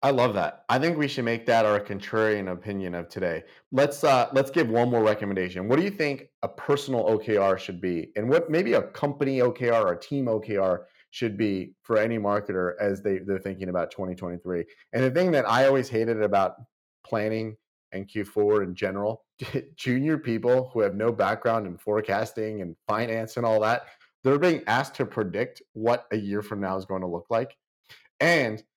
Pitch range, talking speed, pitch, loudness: 100-130 Hz, 195 wpm, 110 Hz, -26 LUFS